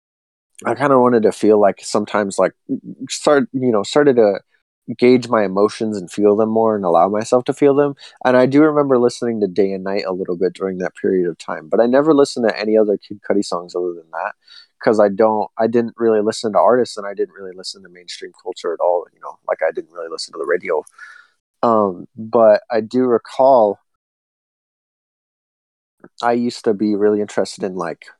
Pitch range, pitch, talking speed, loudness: 105-140 Hz, 115 Hz, 210 wpm, -17 LUFS